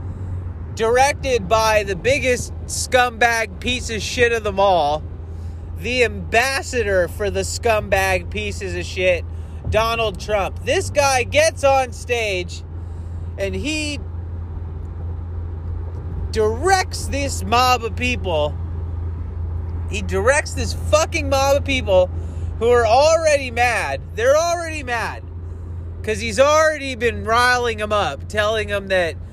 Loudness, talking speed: -19 LUFS, 115 wpm